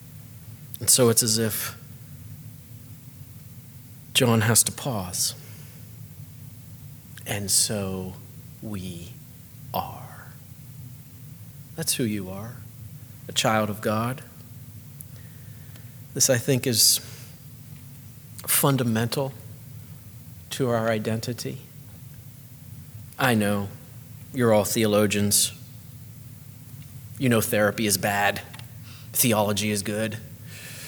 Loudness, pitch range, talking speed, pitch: -23 LUFS, 115-130 Hz, 80 wpm, 125 Hz